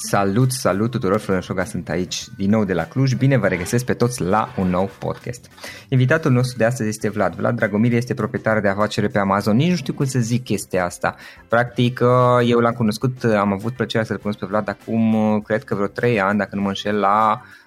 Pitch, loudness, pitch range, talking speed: 110 Hz, -20 LUFS, 100-120 Hz, 220 wpm